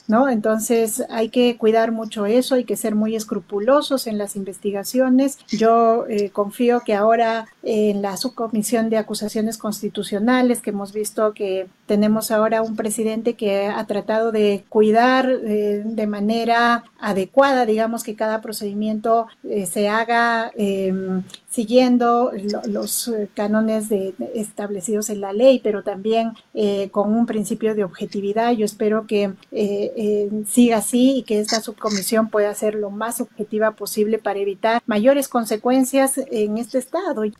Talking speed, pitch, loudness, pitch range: 150 wpm, 220 Hz, -20 LUFS, 210-235 Hz